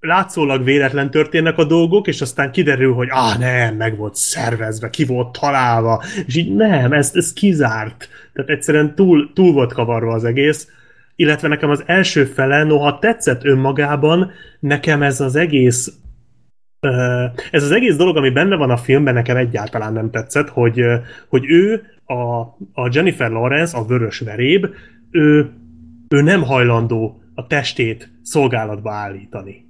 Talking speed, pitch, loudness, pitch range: 145 wpm, 135 Hz, -15 LUFS, 120-155 Hz